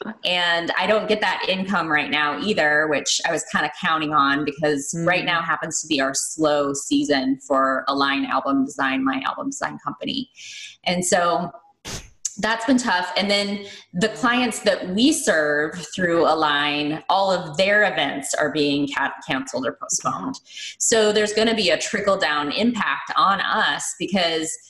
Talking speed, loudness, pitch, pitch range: 165 wpm, -21 LUFS, 170 Hz, 150-210 Hz